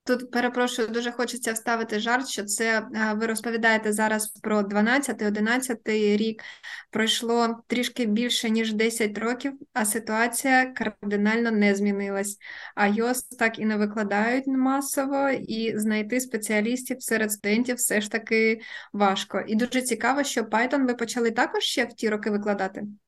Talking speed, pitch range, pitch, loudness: 145 wpm, 215-245 Hz, 225 Hz, -25 LUFS